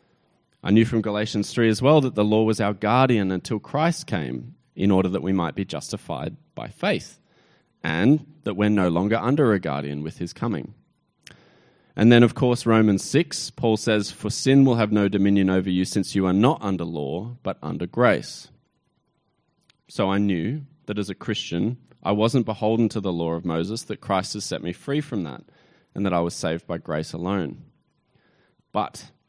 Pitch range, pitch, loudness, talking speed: 95-115 Hz, 105 Hz, -23 LUFS, 190 wpm